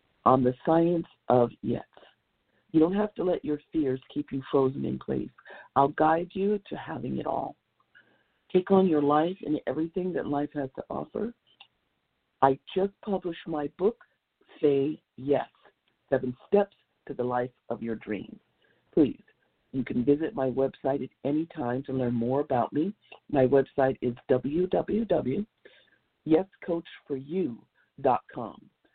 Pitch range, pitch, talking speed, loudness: 130-170 Hz, 145 Hz, 140 wpm, -28 LUFS